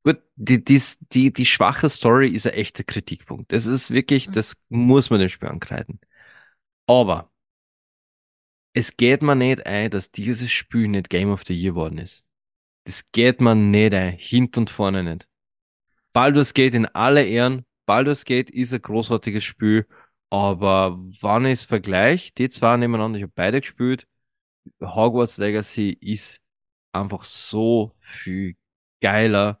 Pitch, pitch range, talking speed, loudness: 110 Hz, 100-125 Hz, 150 wpm, -20 LUFS